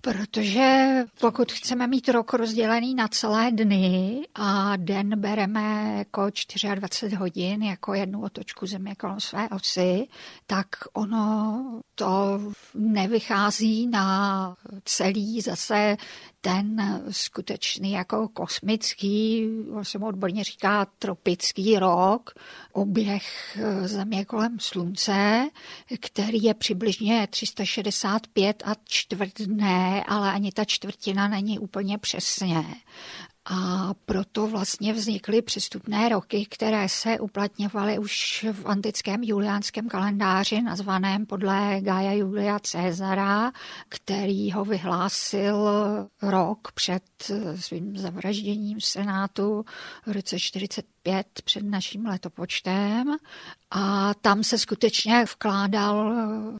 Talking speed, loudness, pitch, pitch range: 100 wpm, -25 LUFS, 205 Hz, 195-220 Hz